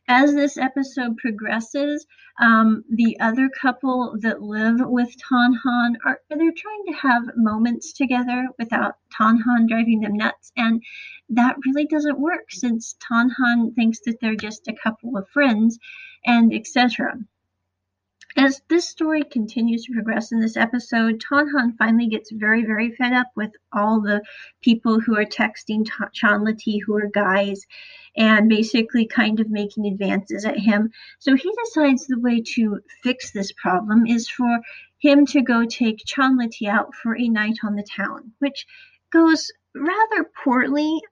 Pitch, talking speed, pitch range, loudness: 235 Hz, 155 wpm, 220-270 Hz, -20 LUFS